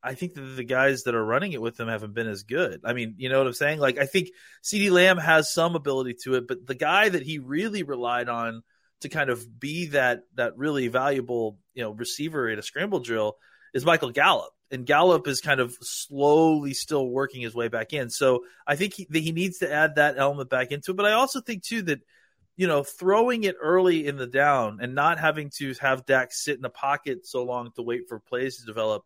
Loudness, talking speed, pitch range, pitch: -25 LUFS, 240 wpm, 125-160 Hz, 140 Hz